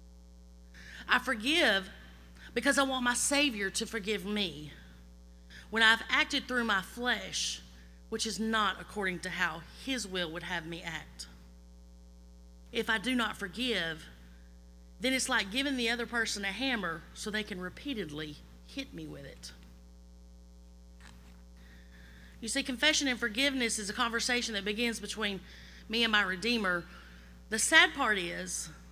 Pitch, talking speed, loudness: 190 Hz, 145 wpm, -31 LUFS